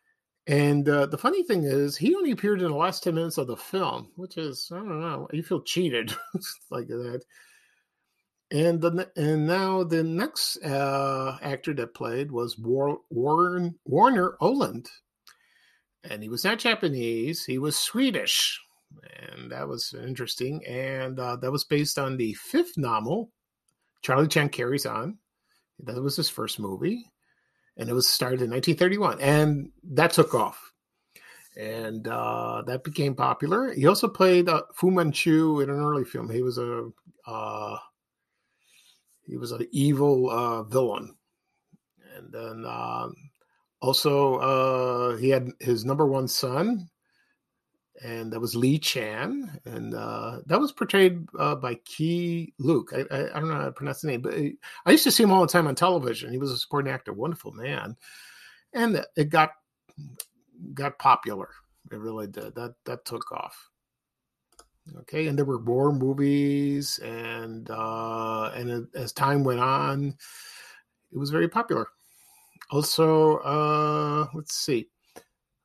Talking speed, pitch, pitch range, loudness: 155 wpm, 145 Hz, 125-170 Hz, -26 LUFS